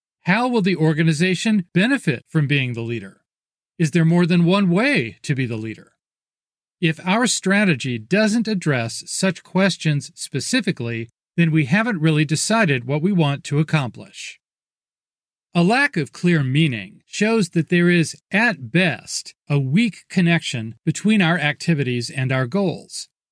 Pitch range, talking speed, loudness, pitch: 145-190 Hz, 145 wpm, -19 LUFS, 165 Hz